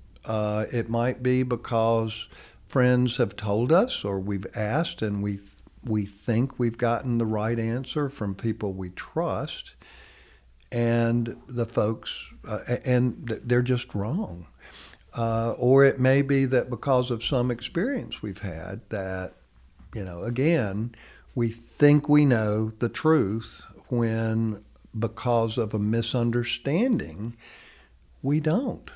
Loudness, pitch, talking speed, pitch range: -26 LUFS, 115 Hz, 135 wpm, 105-125 Hz